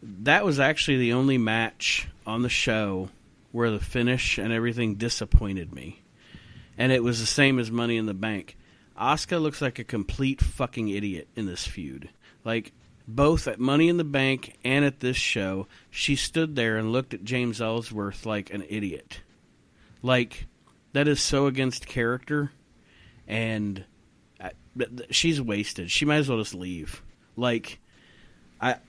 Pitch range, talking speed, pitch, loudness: 105-130 Hz, 160 wpm, 115 Hz, -26 LUFS